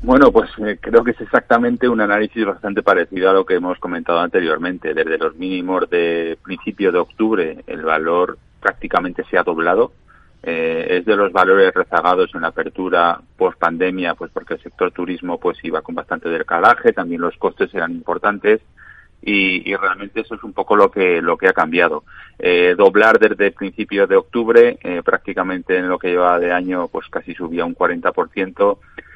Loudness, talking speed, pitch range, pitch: -17 LUFS, 185 wpm, 90-115 Hz, 95 Hz